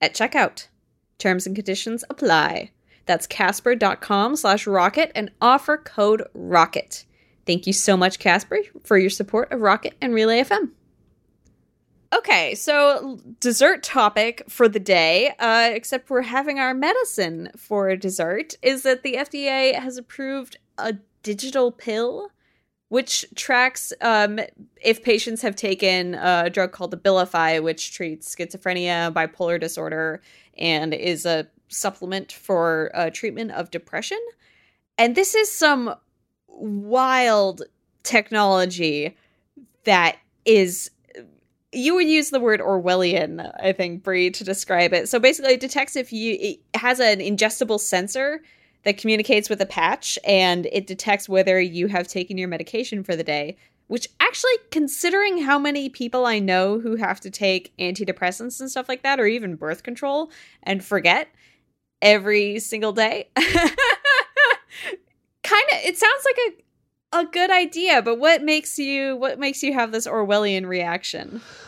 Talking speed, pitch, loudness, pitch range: 145 wpm, 220 Hz, -20 LUFS, 185-265 Hz